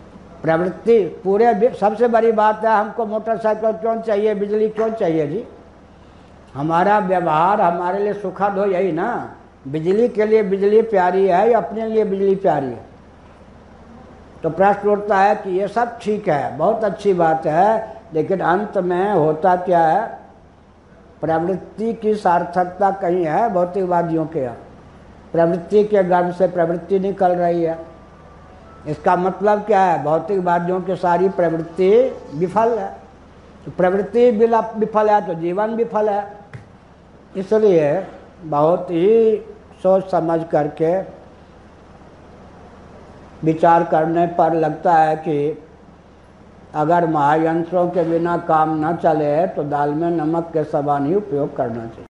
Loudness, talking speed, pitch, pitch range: -18 LUFS, 135 wpm, 175 Hz, 155-205 Hz